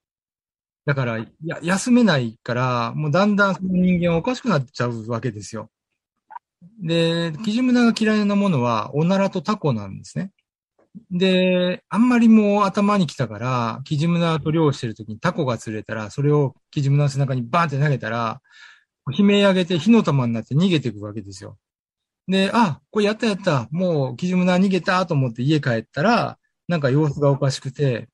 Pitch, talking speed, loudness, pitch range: 160 Hz, 360 characters per minute, -20 LUFS, 125-190 Hz